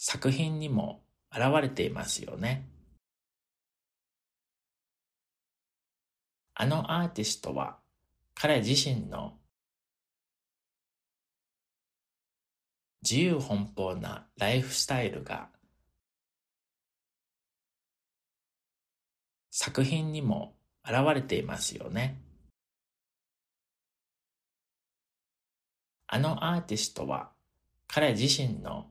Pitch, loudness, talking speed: 105 Hz, -30 LUFS, 130 characters per minute